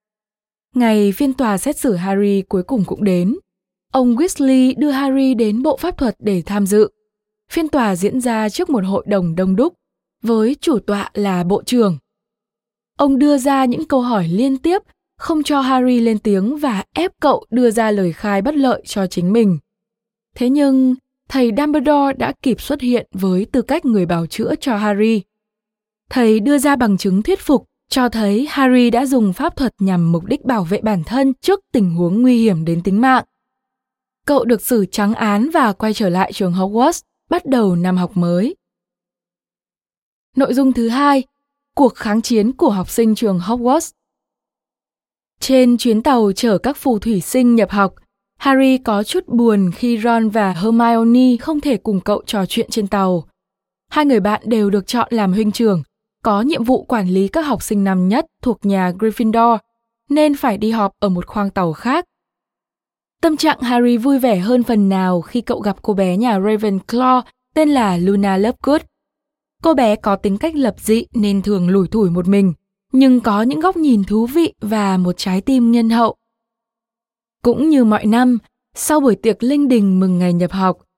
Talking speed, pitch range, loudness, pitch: 185 wpm, 205-265 Hz, -16 LUFS, 230 Hz